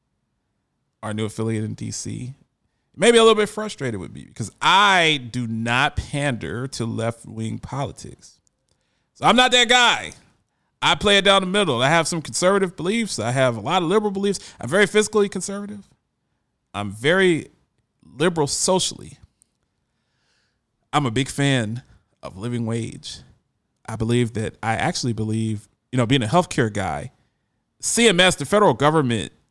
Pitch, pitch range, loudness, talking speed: 135 Hz, 115-190 Hz, -20 LUFS, 150 wpm